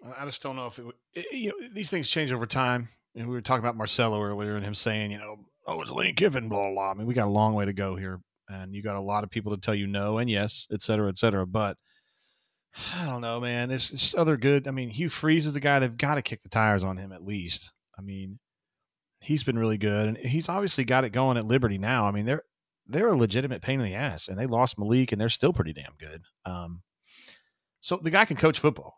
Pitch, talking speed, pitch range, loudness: 115 Hz, 270 wpm, 100-130 Hz, -27 LUFS